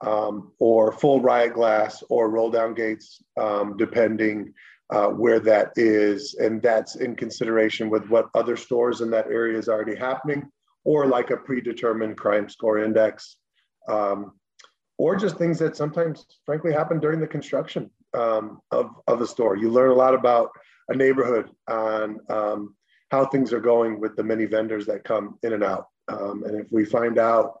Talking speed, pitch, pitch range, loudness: 175 wpm, 115 Hz, 110-130 Hz, -23 LUFS